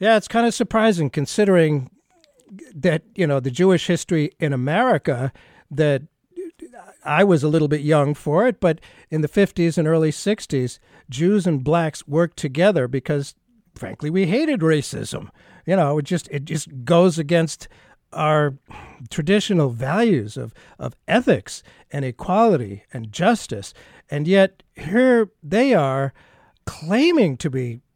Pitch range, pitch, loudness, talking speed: 145-200 Hz, 165 Hz, -20 LUFS, 140 wpm